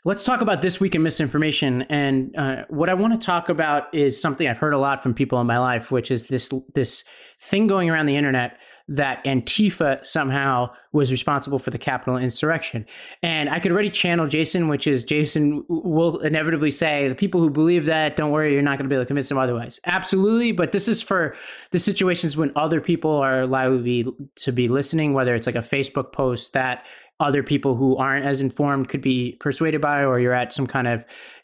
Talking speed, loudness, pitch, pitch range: 215 wpm, -21 LUFS, 145 Hz, 130-165 Hz